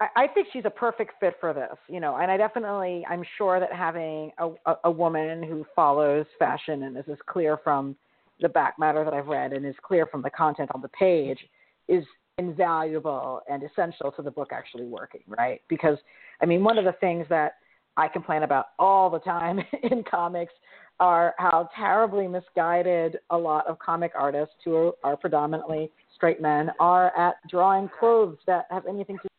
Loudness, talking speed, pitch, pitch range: -25 LUFS, 185 wpm, 170 Hz, 155-185 Hz